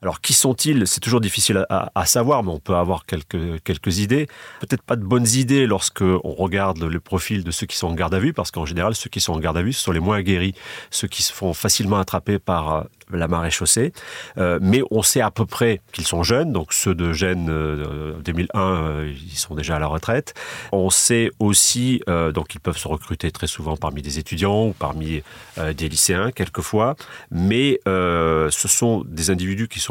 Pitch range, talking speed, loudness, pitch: 85-110 Hz, 225 wpm, -20 LUFS, 95 Hz